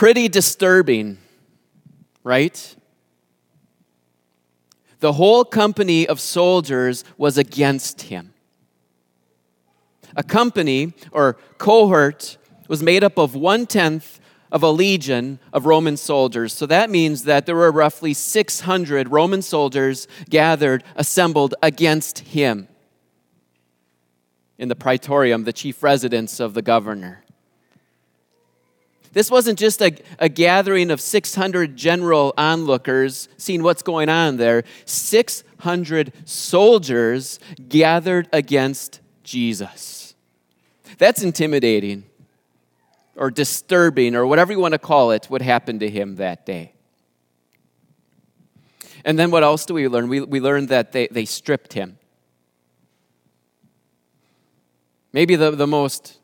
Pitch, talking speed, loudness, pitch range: 140 Hz, 115 wpm, -17 LUFS, 105-170 Hz